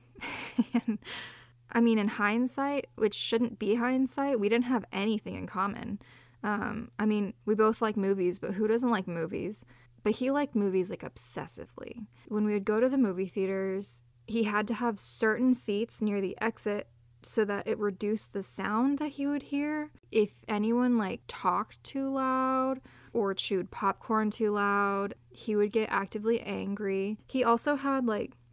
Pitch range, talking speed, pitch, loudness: 200-240 Hz, 170 wpm, 215 Hz, -30 LUFS